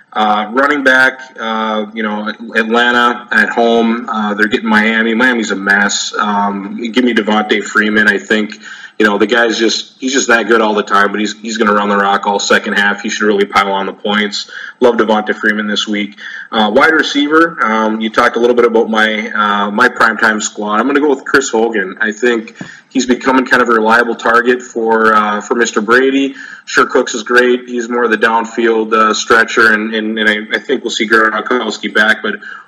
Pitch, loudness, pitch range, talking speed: 110 Hz, -12 LUFS, 105-120 Hz, 215 wpm